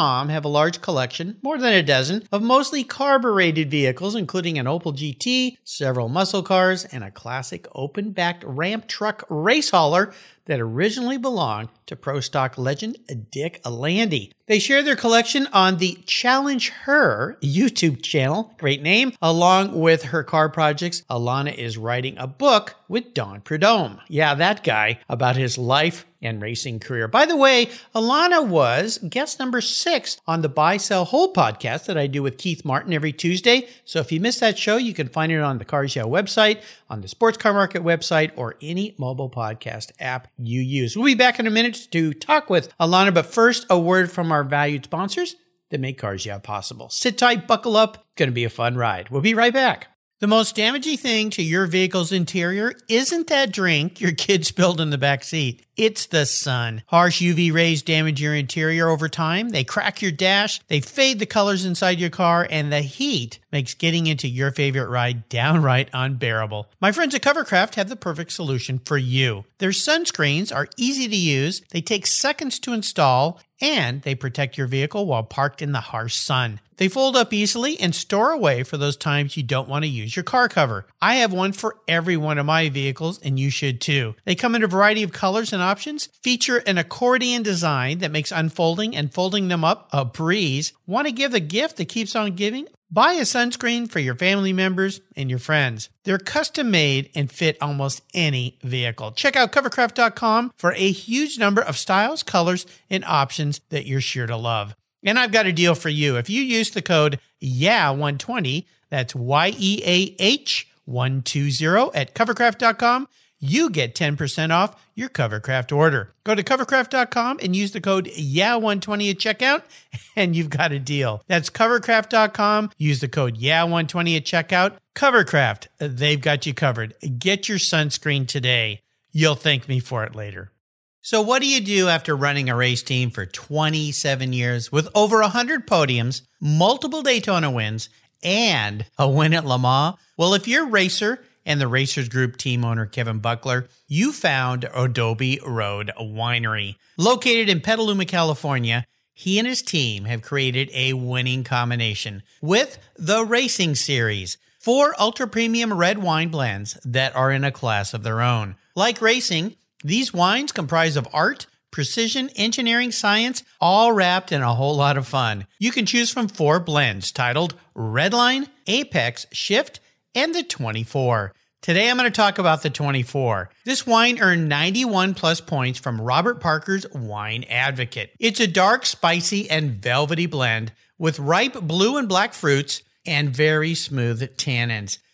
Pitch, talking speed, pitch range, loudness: 165 Hz, 180 wpm, 135-215 Hz, -20 LUFS